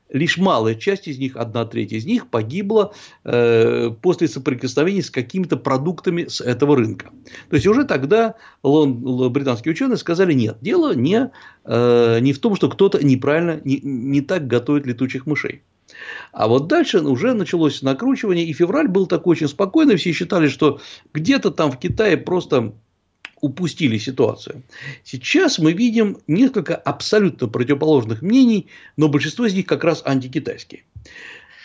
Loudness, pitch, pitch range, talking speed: -18 LUFS, 155 Hz, 135-185 Hz, 150 wpm